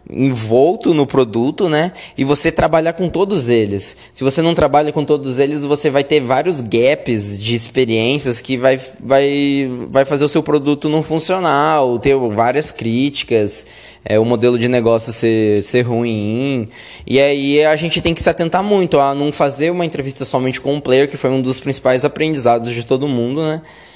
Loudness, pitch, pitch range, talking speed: -15 LUFS, 135 Hz, 120-150 Hz, 190 wpm